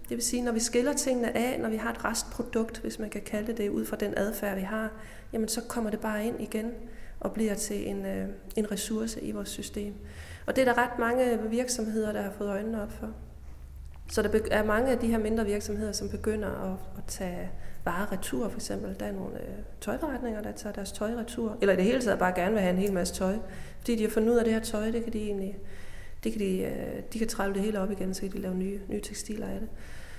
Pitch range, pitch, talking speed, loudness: 180-225 Hz, 210 Hz, 245 wpm, -31 LUFS